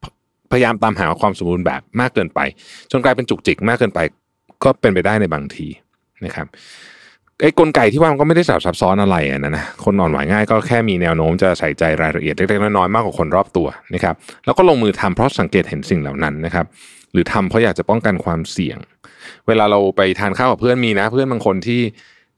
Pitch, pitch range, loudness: 100 Hz, 85-115 Hz, -16 LUFS